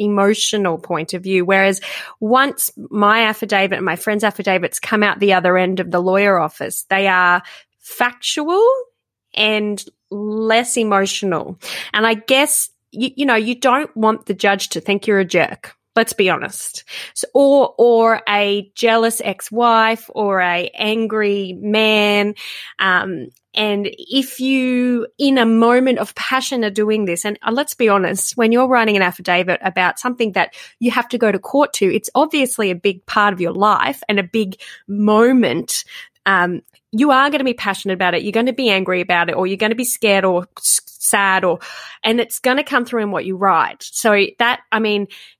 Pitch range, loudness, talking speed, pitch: 195-245 Hz, -16 LUFS, 185 wpm, 215 Hz